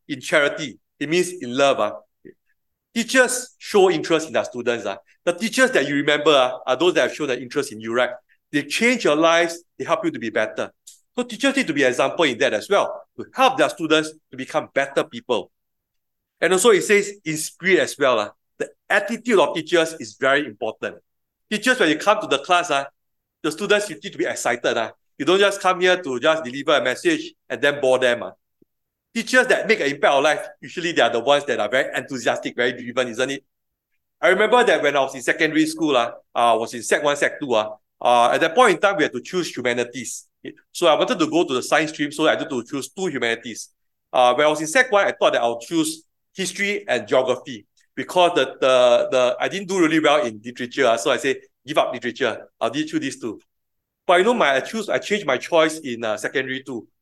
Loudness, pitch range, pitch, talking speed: -20 LUFS, 125-200 Hz, 155 Hz, 235 wpm